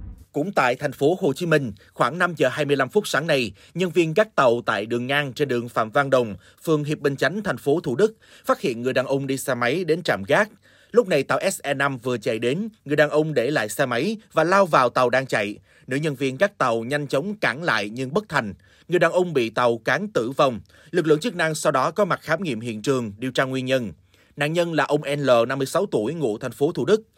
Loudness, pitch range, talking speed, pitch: -22 LUFS, 125-165 Hz, 250 wpm, 140 Hz